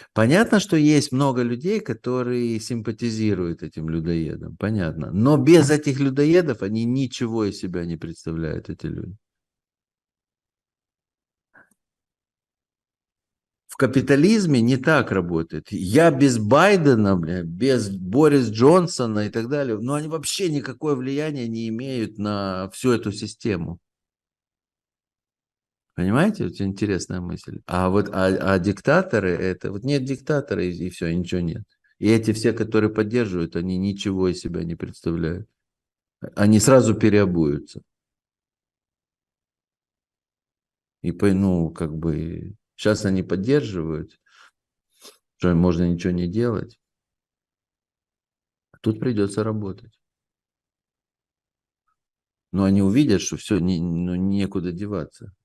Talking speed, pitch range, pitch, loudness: 115 wpm, 90-130 Hz, 105 Hz, -21 LUFS